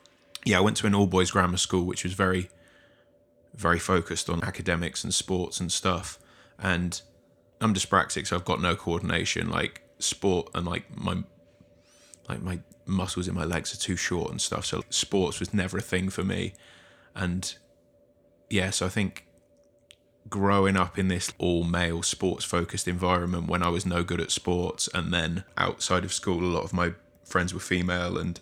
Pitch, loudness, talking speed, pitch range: 90 Hz, -27 LUFS, 175 wpm, 85-95 Hz